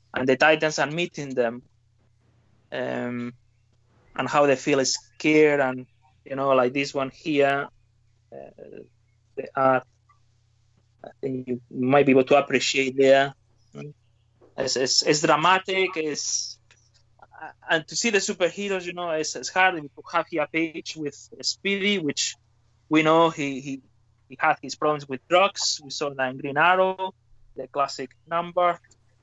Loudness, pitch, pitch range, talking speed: -23 LUFS, 135 Hz, 115-155 Hz, 155 wpm